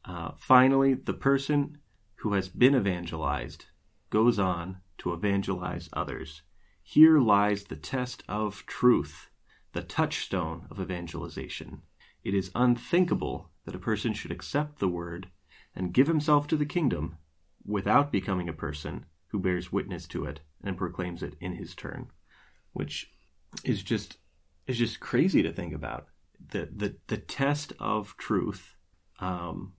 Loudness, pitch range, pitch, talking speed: -29 LUFS, 85-120 Hz, 95 Hz, 140 wpm